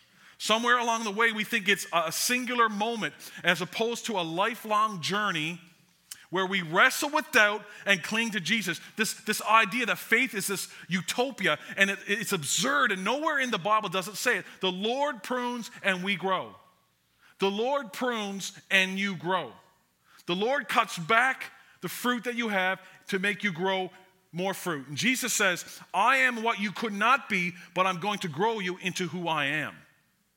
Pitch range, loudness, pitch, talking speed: 185-230 Hz, -27 LUFS, 200 Hz, 185 wpm